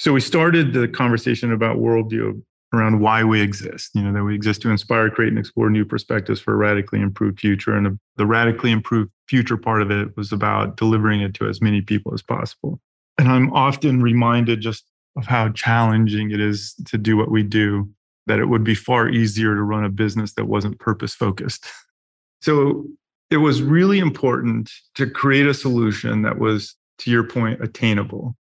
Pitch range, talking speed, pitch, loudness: 105-120 Hz, 190 wpm, 110 Hz, -19 LUFS